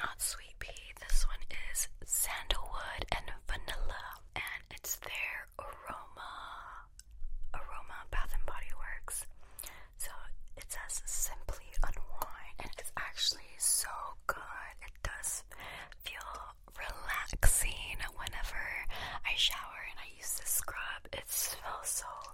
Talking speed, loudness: 115 wpm, -38 LUFS